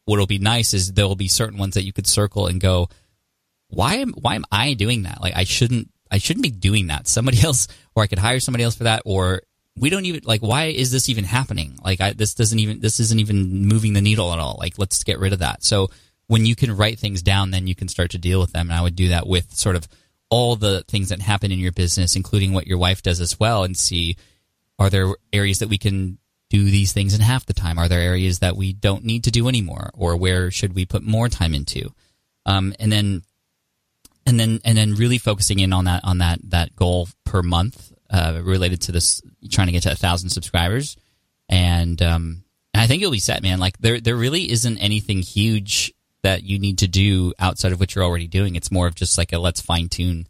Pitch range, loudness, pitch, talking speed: 90-110 Hz, -19 LUFS, 95 Hz, 245 wpm